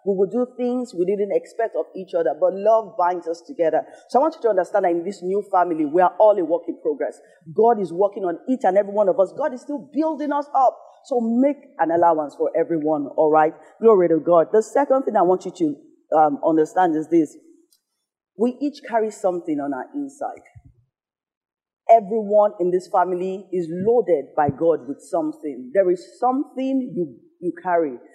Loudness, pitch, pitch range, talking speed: -21 LUFS, 200 Hz, 170-265 Hz, 200 wpm